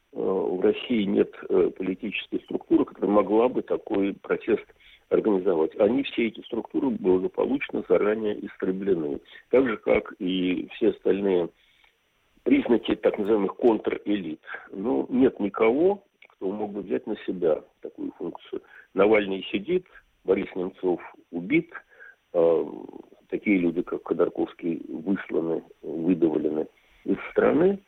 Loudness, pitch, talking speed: -26 LUFS, 370 Hz, 110 wpm